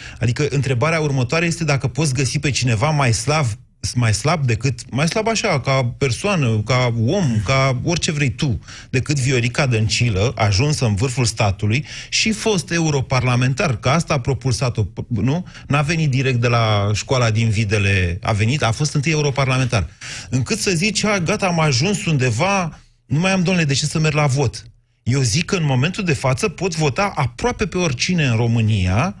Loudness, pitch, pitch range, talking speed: -18 LUFS, 135 Hz, 120-155 Hz, 175 wpm